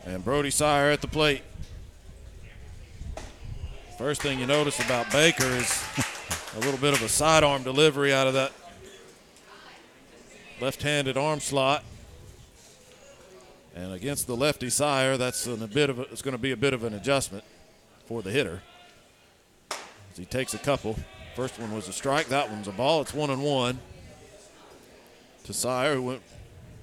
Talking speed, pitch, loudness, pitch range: 160 wpm, 125 Hz, -26 LUFS, 105-140 Hz